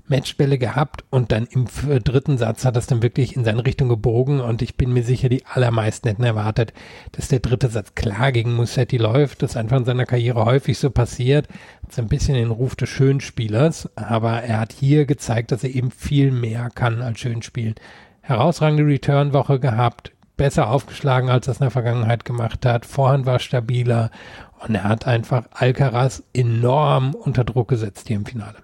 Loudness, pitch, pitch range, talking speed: -20 LUFS, 125 Hz, 115-135 Hz, 185 wpm